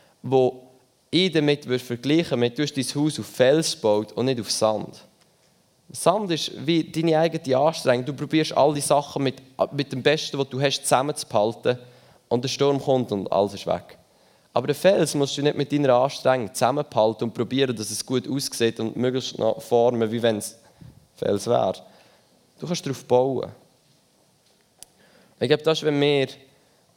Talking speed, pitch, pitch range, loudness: 175 wpm, 135 Hz, 120-150 Hz, -23 LUFS